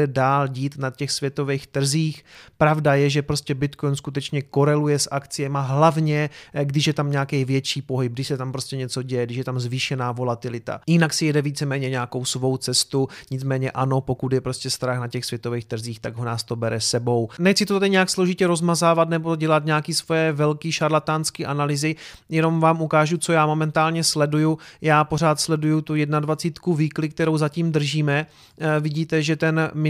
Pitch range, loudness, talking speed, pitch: 130-155 Hz, -22 LUFS, 175 wpm, 145 Hz